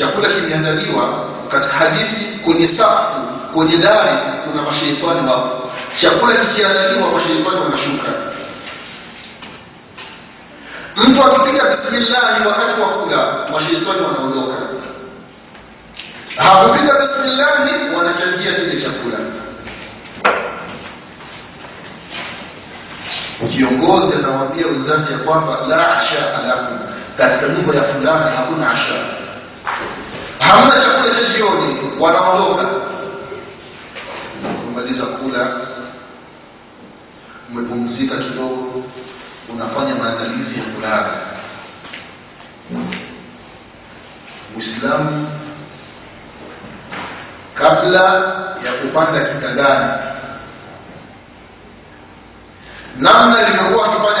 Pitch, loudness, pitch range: 160 Hz, -14 LUFS, 130-210 Hz